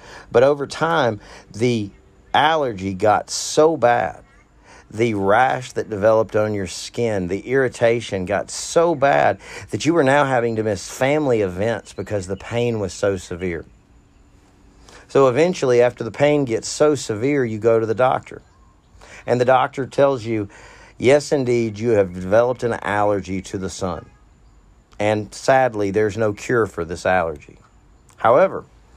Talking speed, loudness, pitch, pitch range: 150 wpm, -19 LUFS, 110 Hz, 100-130 Hz